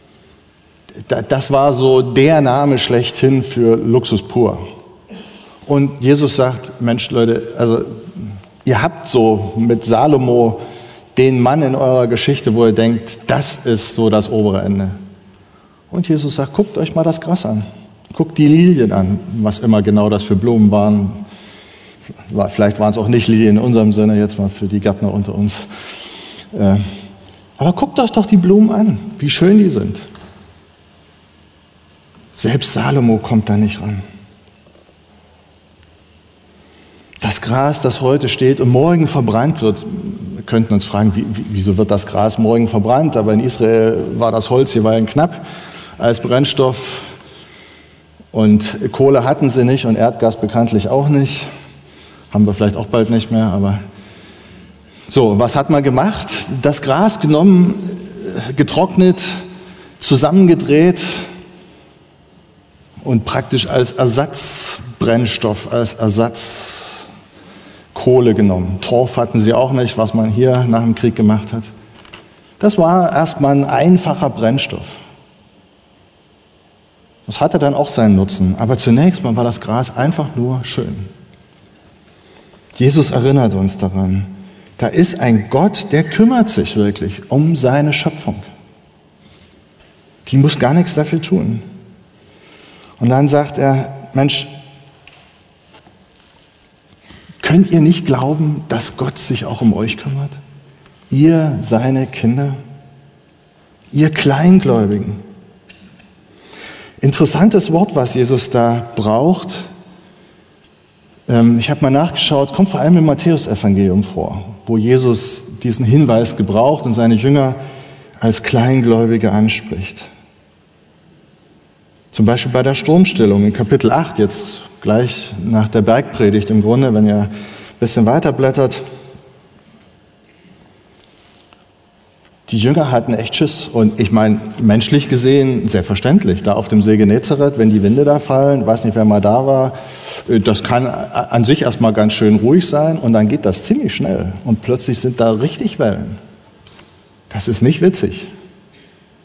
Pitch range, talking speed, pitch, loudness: 105-145 Hz, 130 wpm, 120 Hz, -13 LUFS